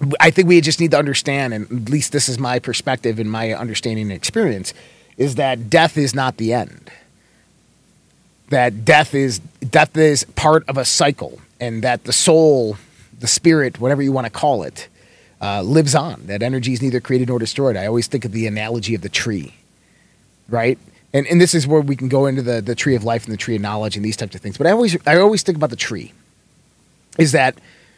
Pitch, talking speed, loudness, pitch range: 125 Hz, 220 wpm, -17 LUFS, 115-145 Hz